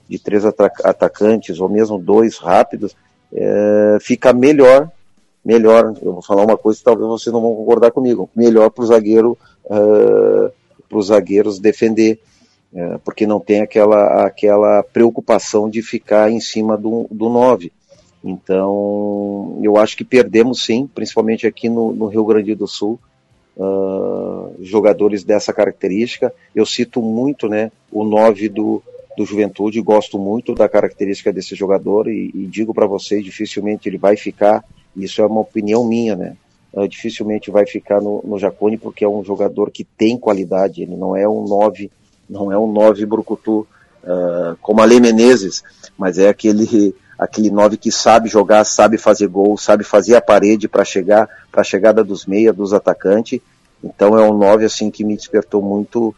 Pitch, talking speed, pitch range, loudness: 105 Hz, 165 wpm, 100-110 Hz, -14 LUFS